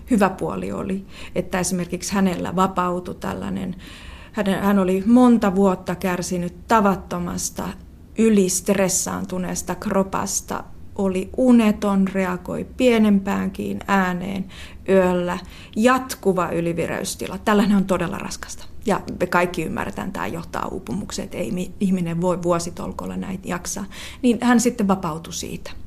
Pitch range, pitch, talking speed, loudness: 180-205 Hz, 190 Hz, 110 wpm, -21 LUFS